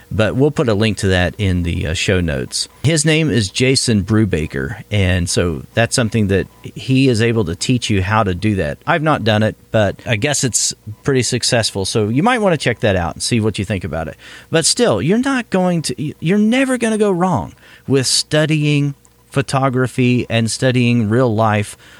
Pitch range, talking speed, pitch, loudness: 100-140 Hz, 205 wpm, 115 Hz, -16 LUFS